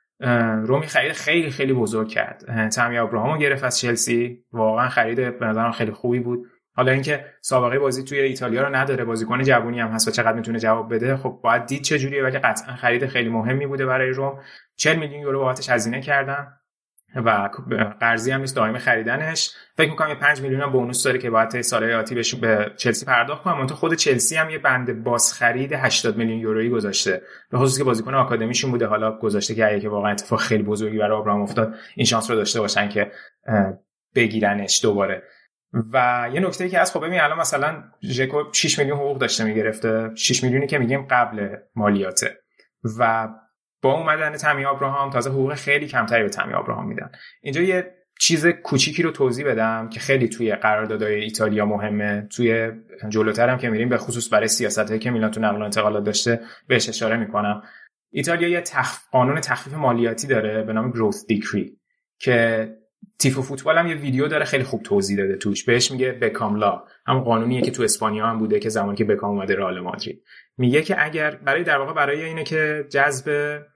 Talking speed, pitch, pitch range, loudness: 185 wpm, 120 Hz, 110-140 Hz, -21 LUFS